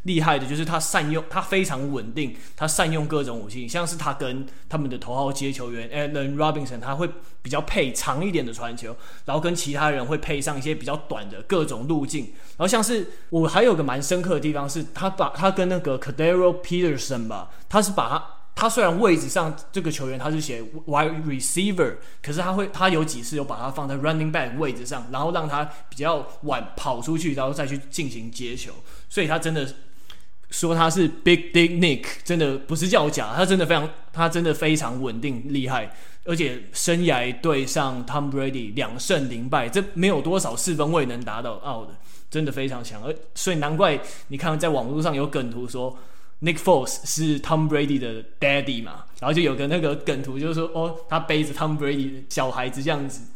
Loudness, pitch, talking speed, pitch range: -24 LUFS, 150 Hz, 370 characters per minute, 135-165 Hz